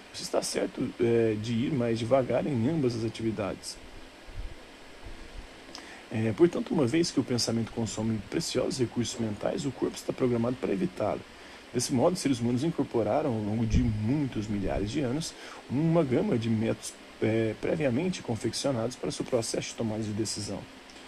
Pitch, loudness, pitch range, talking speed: 115 Hz, -29 LUFS, 110-125 Hz, 155 wpm